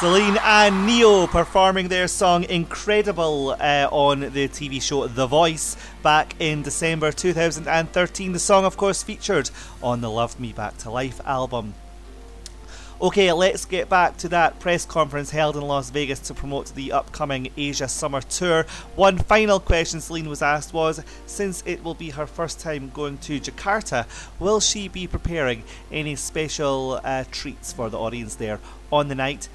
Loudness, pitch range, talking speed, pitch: -22 LUFS, 130-175 Hz, 165 wpm, 150 Hz